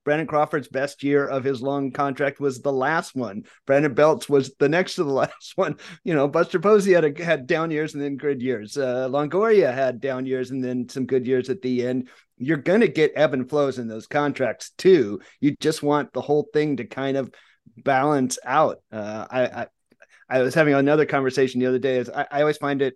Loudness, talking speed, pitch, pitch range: -22 LUFS, 220 wpm, 140 Hz, 130-150 Hz